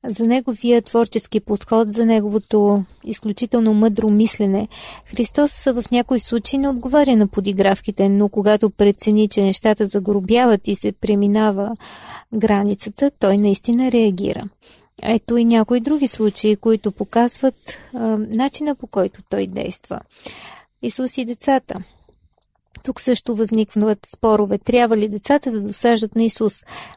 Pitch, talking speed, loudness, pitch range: 220 Hz, 125 wpm, -18 LUFS, 210-240 Hz